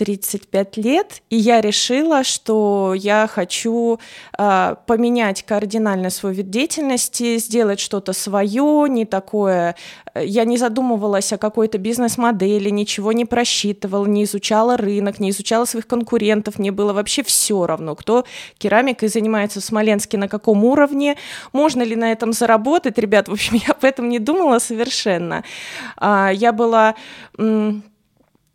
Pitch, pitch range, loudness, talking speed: 220 Hz, 205-240 Hz, -17 LUFS, 140 wpm